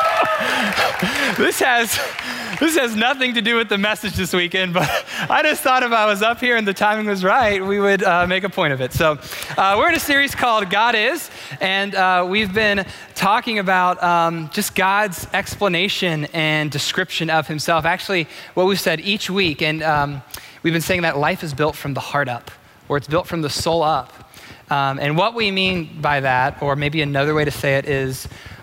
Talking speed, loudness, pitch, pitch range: 205 wpm, -18 LUFS, 180 Hz, 150-200 Hz